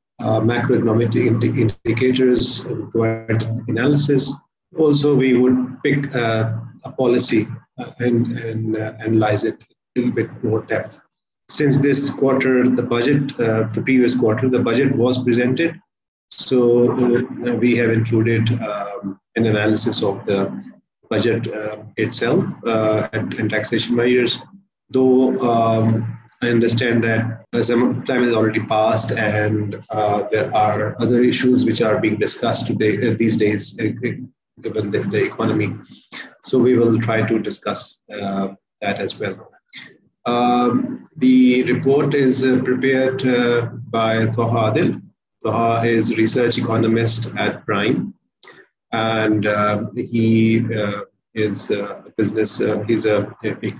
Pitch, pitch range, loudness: 115 Hz, 110-125 Hz, -18 LUFS